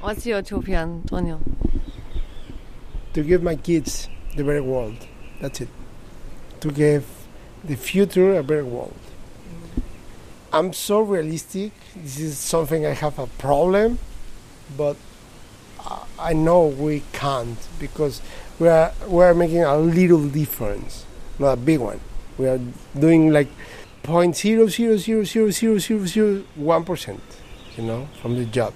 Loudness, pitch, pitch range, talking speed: -21 LUFS, 150 Hz, 130-180 Hz, 120 wpm